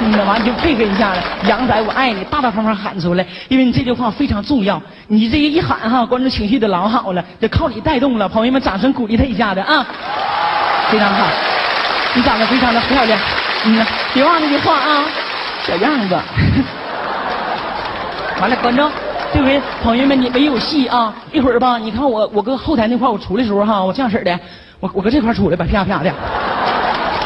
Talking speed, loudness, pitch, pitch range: 300 characters per minute, -15 LUFS, 235 Hz, 205-265 Hz